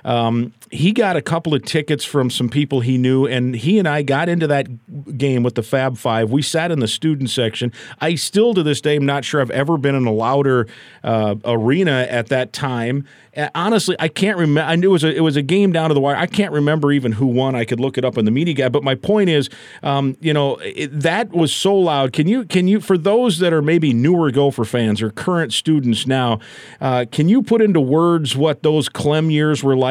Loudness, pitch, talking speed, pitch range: -17 LUFS, 145 Hz, 240 wpm, 130-165 Hz